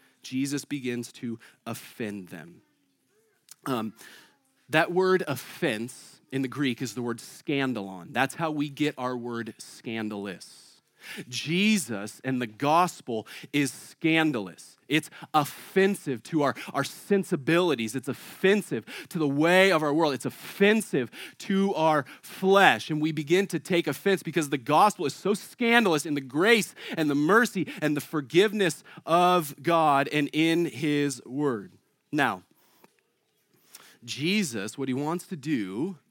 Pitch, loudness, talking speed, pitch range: 150 Hz, -26 LUFS, 135 wpm, 130-175 Hz